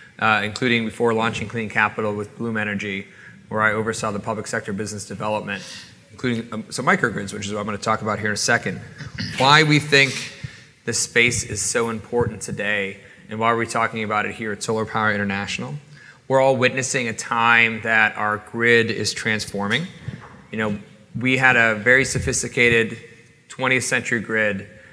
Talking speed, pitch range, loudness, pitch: 180 wpm, 105-120 Hz, -20 LUFS, 115 Hz